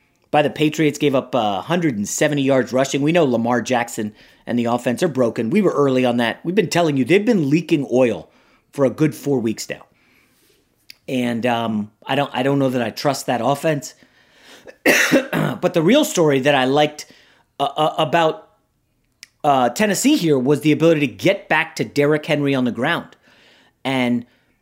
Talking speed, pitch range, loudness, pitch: 175 wpm, 125-160 Hz, -18 LUFS, 145 Hz